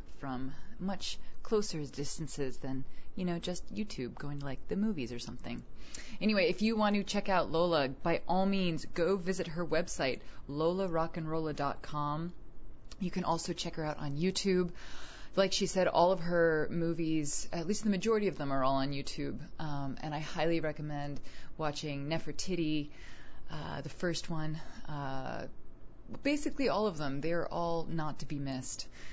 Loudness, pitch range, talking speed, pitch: -35 LUFS, 145-185 Hz, 165 wpm, 160 Hz